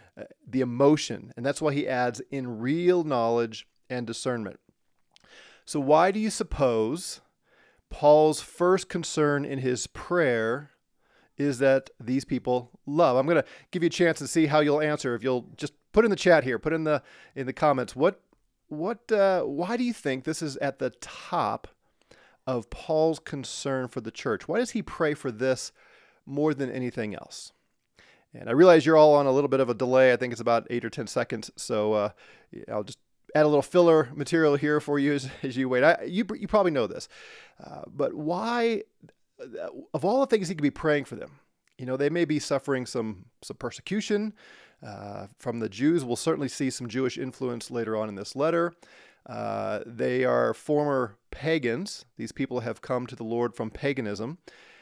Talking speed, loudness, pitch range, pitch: 190 wpm, -26 LUFS, 125-160 Hz, 140 Hz